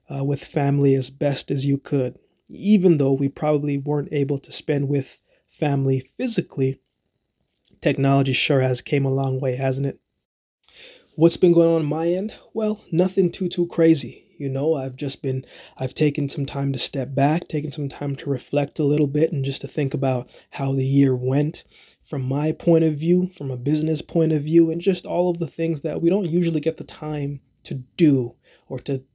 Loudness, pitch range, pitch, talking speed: -22 LUFS, 135-165 Hz, 145 Hz, 200 wpm